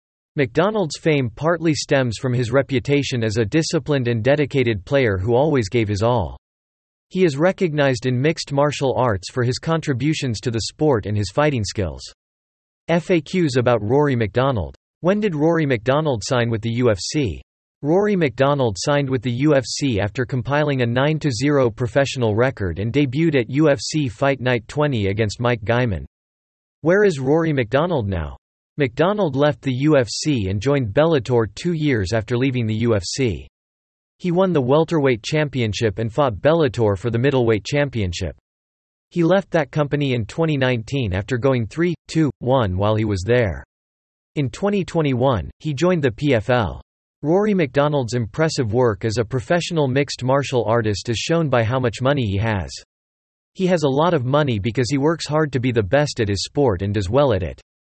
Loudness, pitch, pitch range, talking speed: -20 LUFS, 130 Hz, 110-150 Hz, 165 wpm